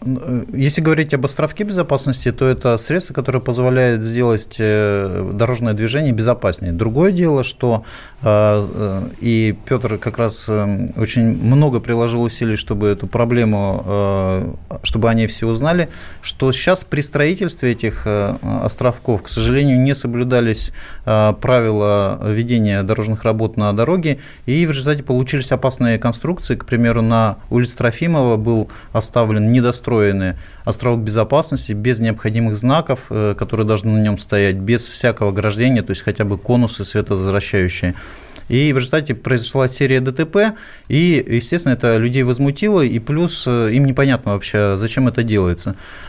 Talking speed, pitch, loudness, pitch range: 130 wpm, 115 Hz, -17 LUFS, 105-130 Hz